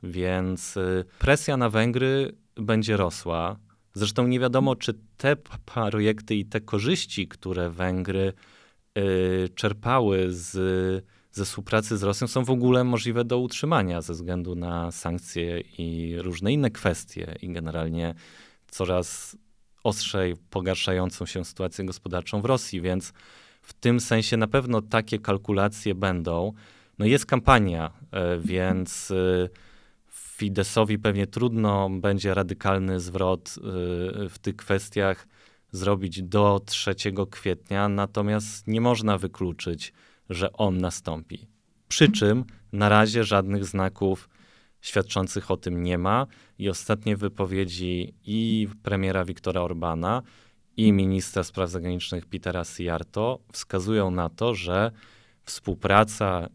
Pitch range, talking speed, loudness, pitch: 90-110 Hz, 120 wpm, -26 LUFS, 100 Hz